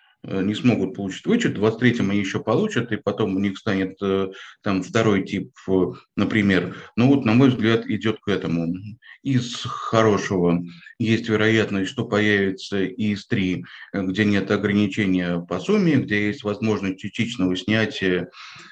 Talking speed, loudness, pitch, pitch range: 145 wpm, -22 LUFS, 105 Hz, 95-110 Hz